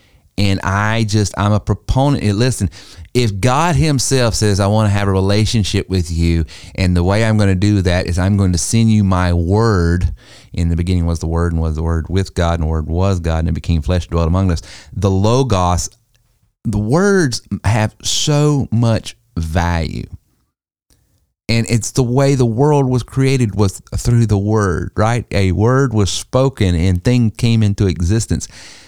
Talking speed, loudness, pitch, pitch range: 185 wpm, -15 LUFS, 100 Hz, 90-115 Hz